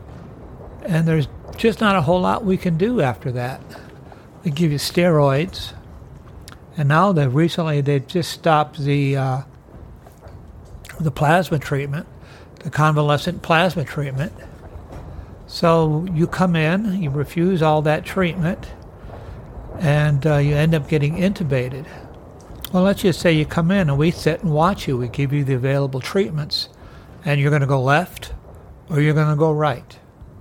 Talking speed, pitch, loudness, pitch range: 155 wpm, 150 Hz, -19 LUFS, 135-170 Hz